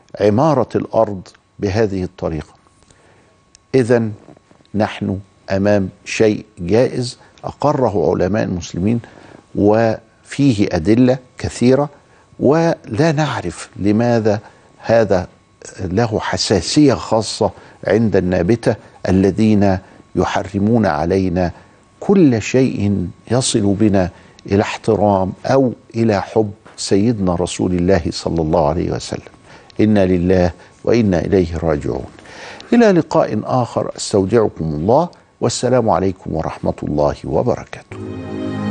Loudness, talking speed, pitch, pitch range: -17 LUFS, 90 wpm, 105 Hz, 95-115 Hz